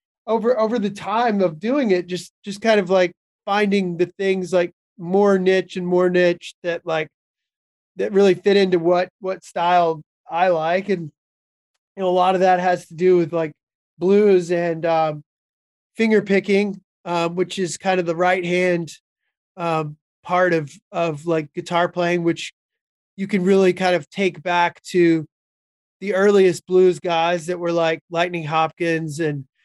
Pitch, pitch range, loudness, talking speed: 180 Hz, 170-190 Hz, -20 LUFS, 170 wpm